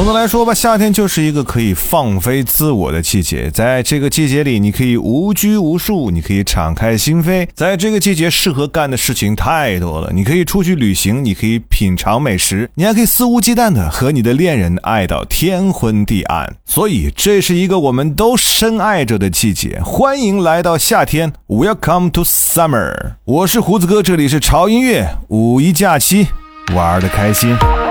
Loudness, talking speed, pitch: -12 LUFS, 310 characters per minute, 145 Hz